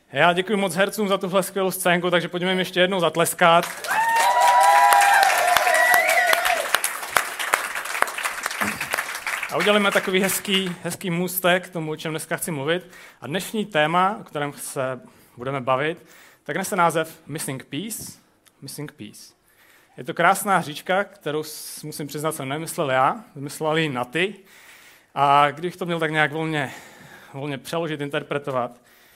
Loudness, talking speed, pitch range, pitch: -21 LUFS, 135 wpm, 150-190 Hz, 170 Hz